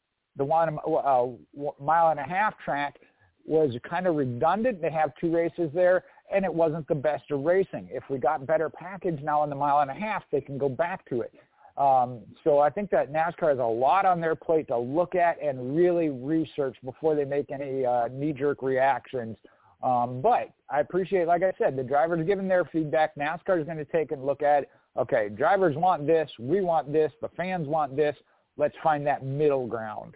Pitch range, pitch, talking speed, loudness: 140-170 Hz, 155 Hz, 205 wpm, -26 LUFS